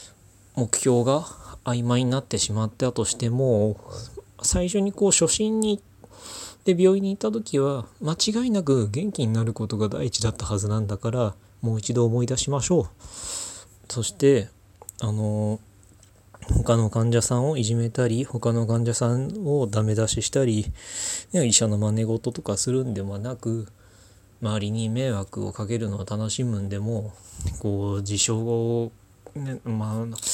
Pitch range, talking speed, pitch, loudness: 105-125 Hz, 285 characters per minute, 115 Hz, -24 LUFS